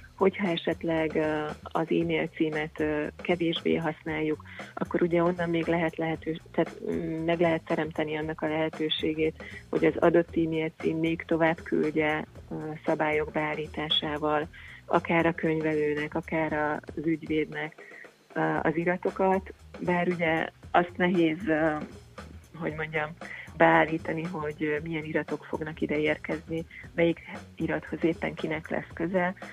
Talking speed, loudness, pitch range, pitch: 115 wpm, -28 LUFS, 155-165 Hz, 160 Hz